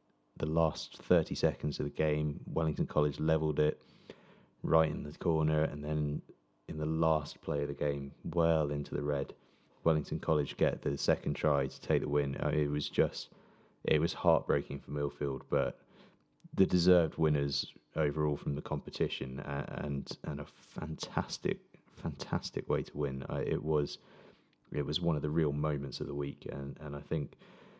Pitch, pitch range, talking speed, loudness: 75 Hz, 70-80 Hz, 170 wpm, -34 LUFS